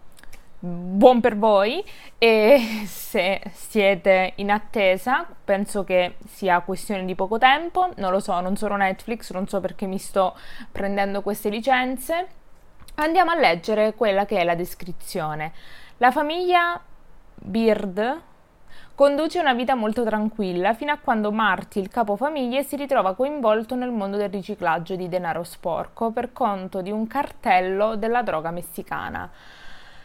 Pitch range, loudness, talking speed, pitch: 190-250 Hz, -22 LUFS, 140 wpm, 210 Hz